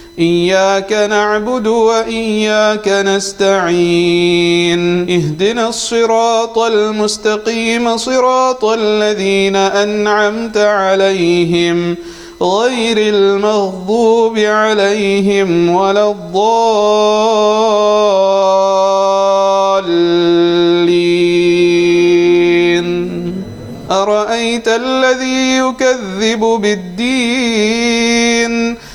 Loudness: -12 LUFS